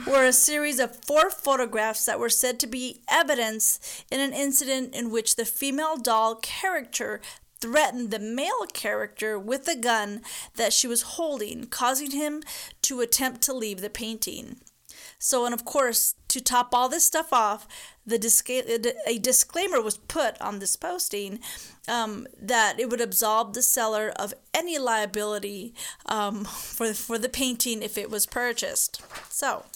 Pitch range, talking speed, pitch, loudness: 225-275 Hz, 160 wpm, 245 Hz, -25 LUFS